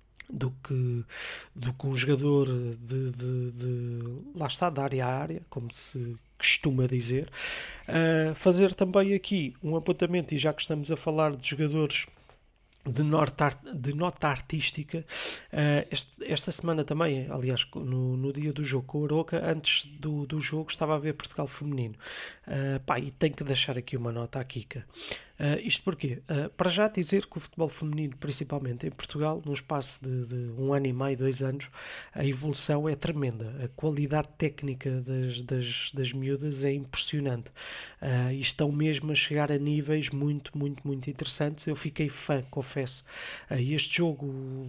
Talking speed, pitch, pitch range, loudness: 175 wpm, 145 Hz, 130-155 Hz, -30 LUFS